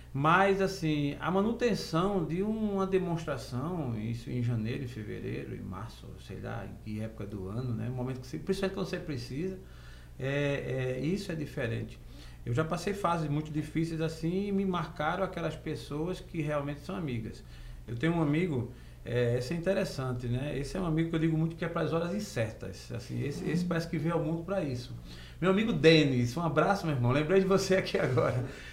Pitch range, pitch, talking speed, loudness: 120-175 Hz, 155 Hz, 195 wpm, -32 LUFS